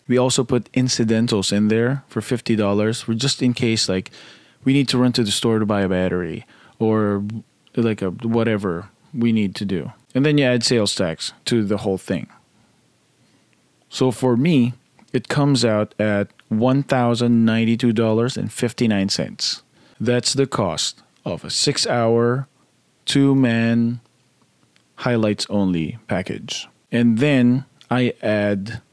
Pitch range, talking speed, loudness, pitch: 105-125 Hz, 155 wpm, -20 LUFS, 115 Hz